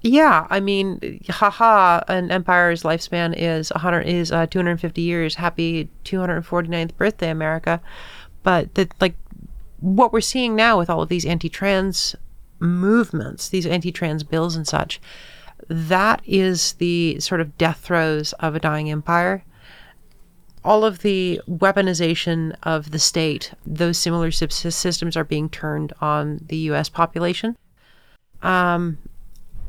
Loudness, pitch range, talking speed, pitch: -20 LUFS, 165-185 Hz, 145 wpm, 170 Hz